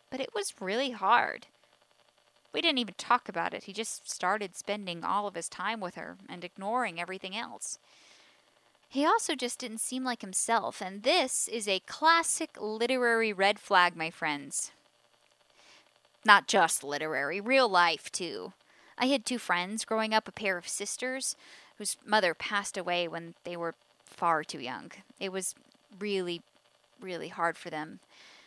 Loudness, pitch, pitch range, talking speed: -30 LUFS, 210 Hz, 180-250 Hz, 160 wpm